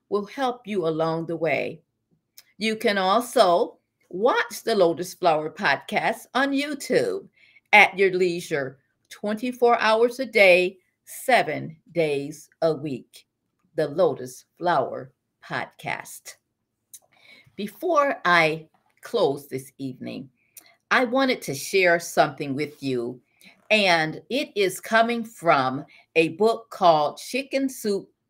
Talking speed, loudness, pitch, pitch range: 110 wpm, -23 LUFS, 185 Hz, 155-230 Hz